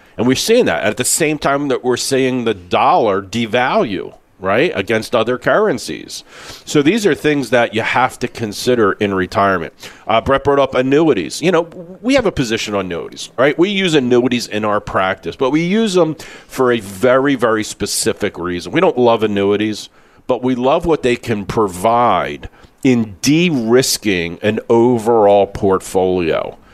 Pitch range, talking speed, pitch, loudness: 105-140 Hz, 170 wpm, 125 Hz, -15 LUFS